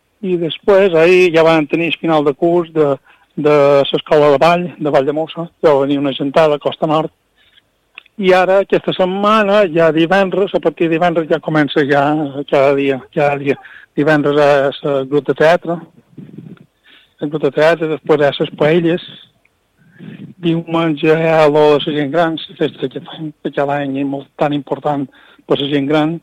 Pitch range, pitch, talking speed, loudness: 145-170 Hz, 155 Hz, 180 wpm, -14 LUFS